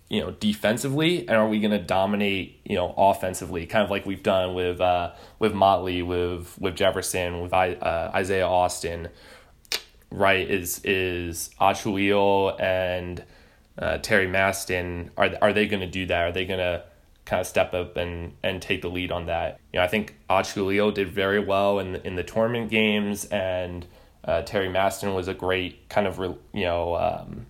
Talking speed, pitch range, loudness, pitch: 185 wpm, 90-100 Hz, -25 LUFS, 95 Hz